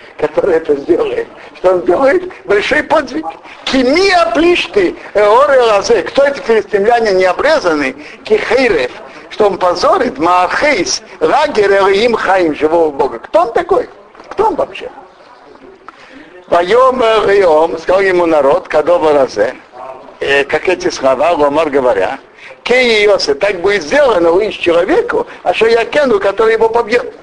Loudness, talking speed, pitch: -11 LUFS, 120 wpm, 230 Hz